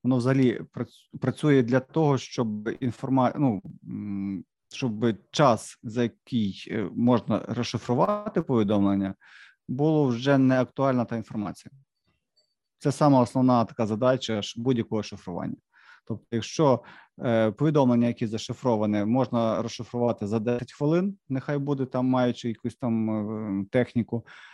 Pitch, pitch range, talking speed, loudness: 120 Hz, 110-130 Hz, 110 wpm, -26 LUFS